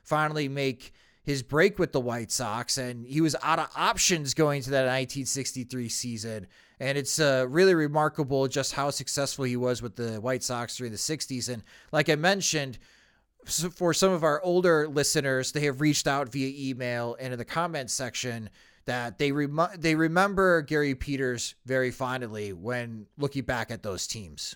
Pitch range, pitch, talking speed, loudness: 125-155 Hz, 135 Hz, 180 wpm, -27 LUFS